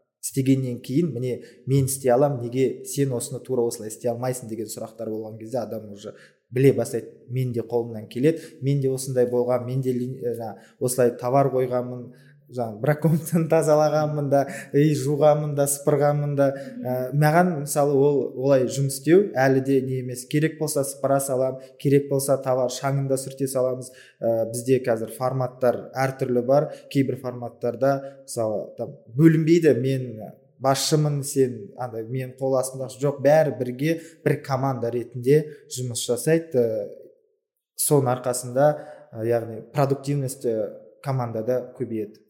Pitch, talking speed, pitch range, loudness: 130 Hz, 135 wpm, 125-145 Hz, -23 LUFS